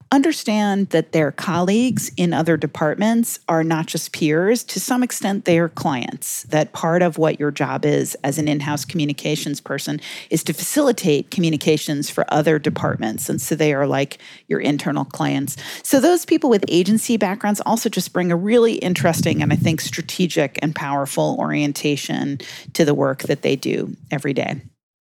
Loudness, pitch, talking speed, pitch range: -19 LUFS, 160 Hz, 175 wpm, 150-195 Hz